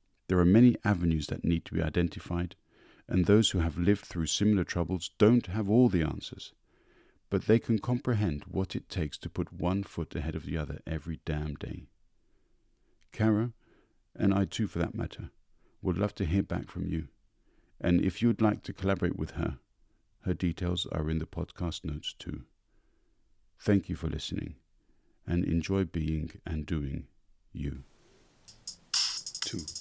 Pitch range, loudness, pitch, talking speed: 80-100 Hz, -30 LUFS, 90 Hz, 165 wpm